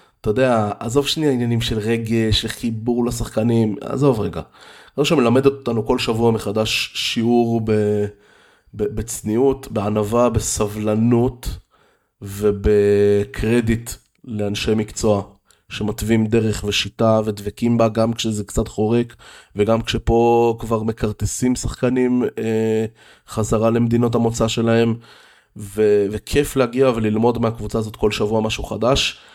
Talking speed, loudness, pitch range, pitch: 110 wpm, -19 LUFS, 105-120 Hz, 115 Hz